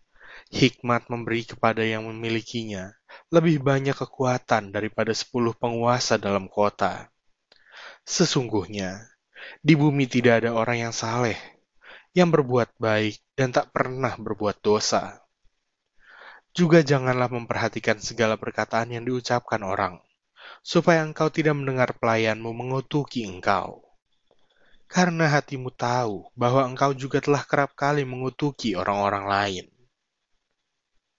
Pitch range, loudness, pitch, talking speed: 110-140 Hz, -24 LUFS, 120 Hz, 110 wpm